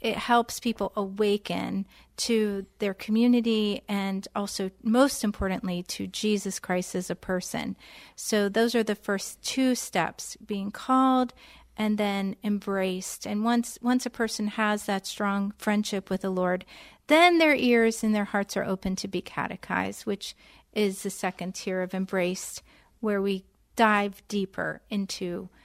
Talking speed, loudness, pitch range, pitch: 150 wpm, -27 LUFS, 195-230 Hz, 205 Hz